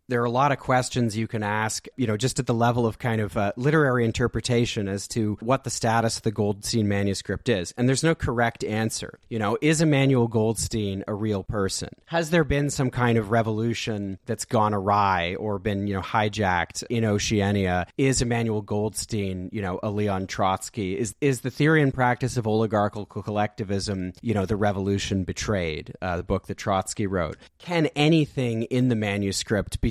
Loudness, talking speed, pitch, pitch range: -25 LUFS, 190 wpm, 110 Hz, 100-120 Hz